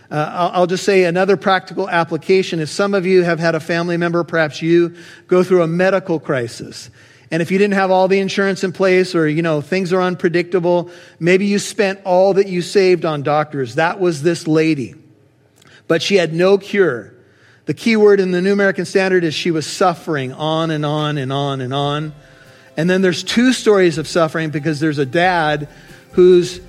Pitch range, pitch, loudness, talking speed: 155-185 Hz, 170 Hz, -16 LUFS, 200 wpm